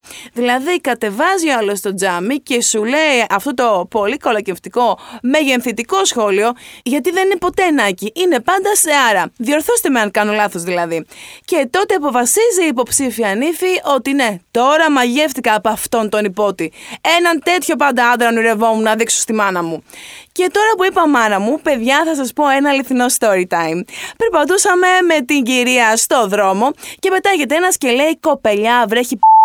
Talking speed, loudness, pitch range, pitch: 165 wpm, -14 LUFS, 220-315 Hz, 255 Hz